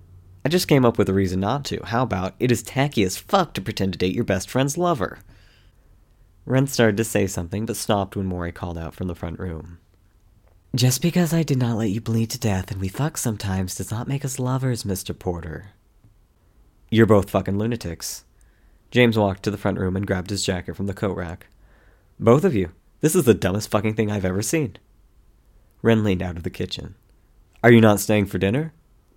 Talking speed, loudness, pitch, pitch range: 210 wpm, -22 LUFS, 100 Hz, 95-115 Hz